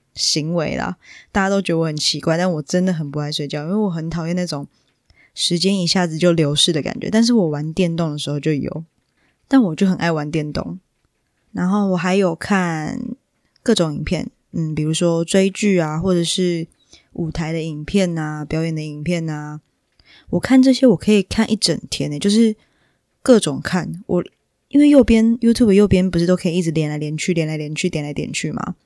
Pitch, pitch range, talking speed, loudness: 170 Hz, 155-195 Hz, 300 characters per minute, -18 LUFS